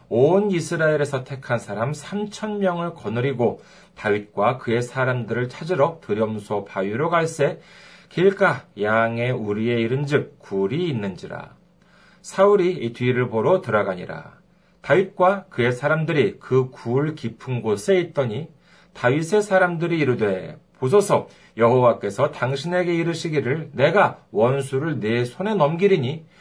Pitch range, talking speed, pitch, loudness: 120-175 Hz, 285 characters per minute, 145 Hz, -22 LUFS